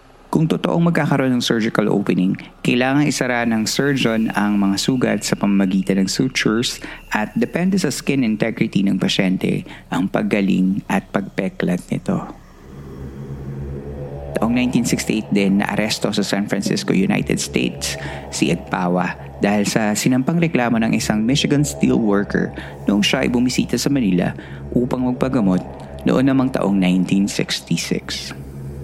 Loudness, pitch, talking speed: -19 LUFS, 100 Hz, 130 wpm